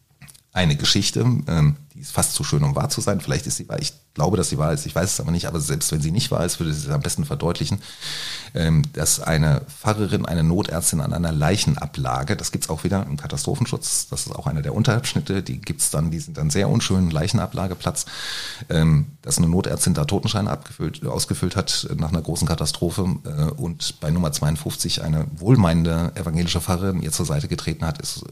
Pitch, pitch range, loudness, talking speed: 85 Hz, 80-115 Hz, -22 LUFS, 205 wpm